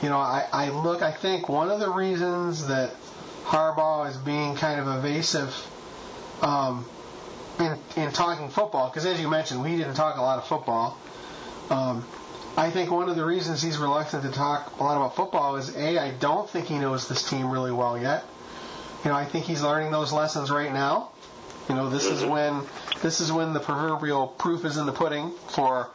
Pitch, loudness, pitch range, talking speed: 150 Hz, -26 LUFS, 135-160 Hz, 200 wpm